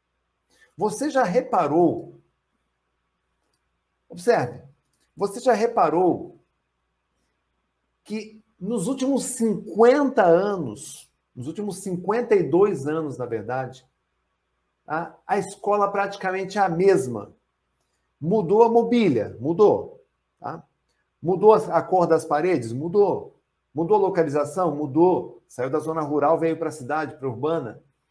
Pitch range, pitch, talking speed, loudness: 145-215 Hz, 180 Hz, 105 wpm, -22 LUFS